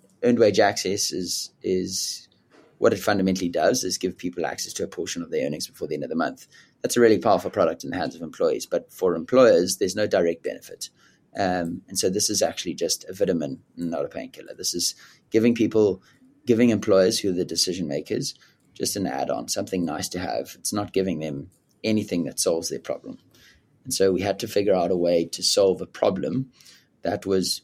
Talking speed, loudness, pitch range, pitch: 210 wpm, -24 LUFS, 90-130 Hz, 100 Hz